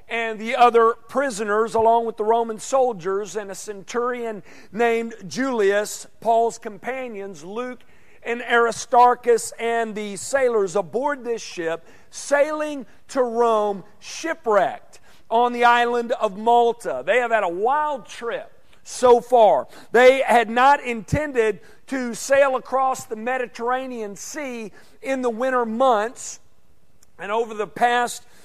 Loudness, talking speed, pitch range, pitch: -21 LUFS, 125 wpm, 220-250 Hz, 235 Hz